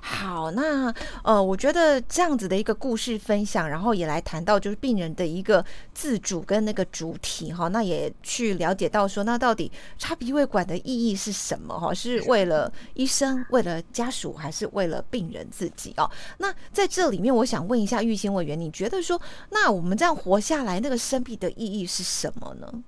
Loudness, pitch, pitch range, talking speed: -25 LUFS, 220 Hz, 185-255 Hz, 300 characters per minute